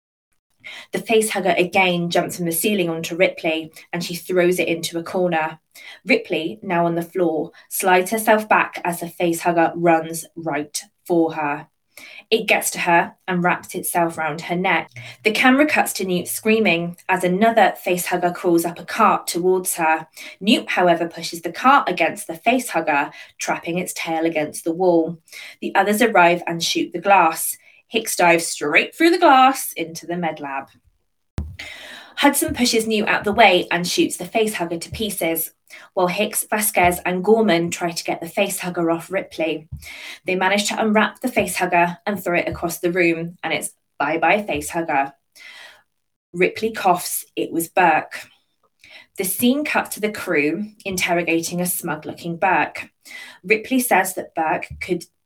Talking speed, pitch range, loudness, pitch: 165 wpm, 165-200 Hz, -19 LUFS, 175 Hz